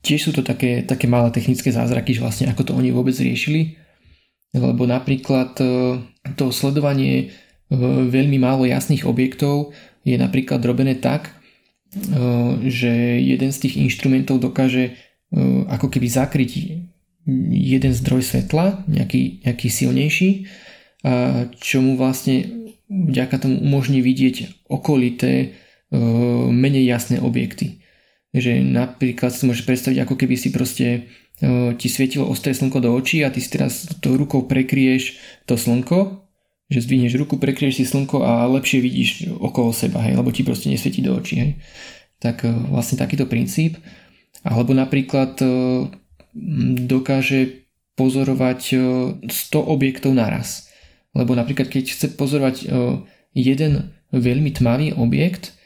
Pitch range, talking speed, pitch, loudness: 125-140 Hz, 130 wpm, 130 Hz, -19 LUFS